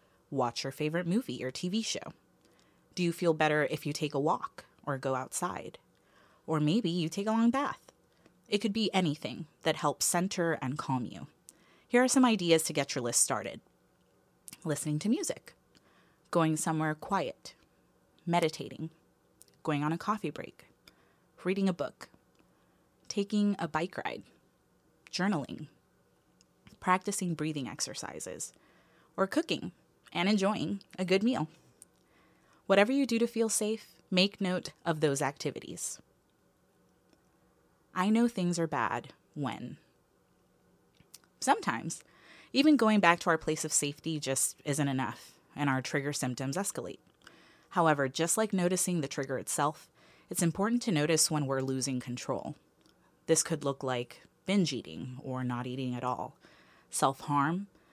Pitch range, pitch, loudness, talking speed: 140-190 Hz, 160 Hz, -31 LUFS, 140 wpm